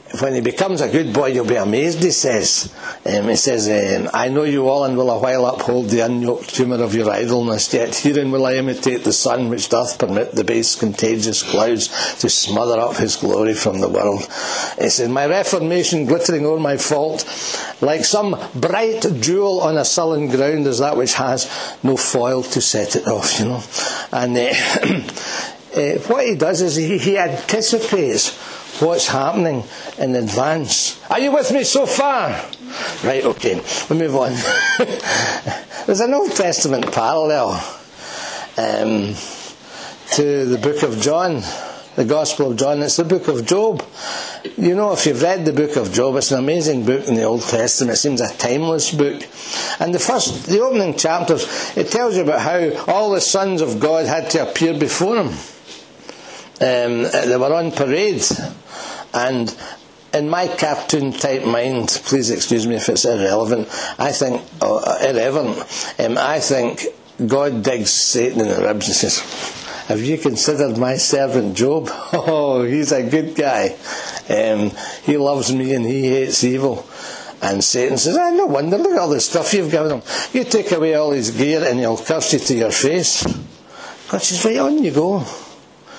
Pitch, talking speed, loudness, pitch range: 145 Hz, 175 wpm, -17 LUFS, 125-170 Hz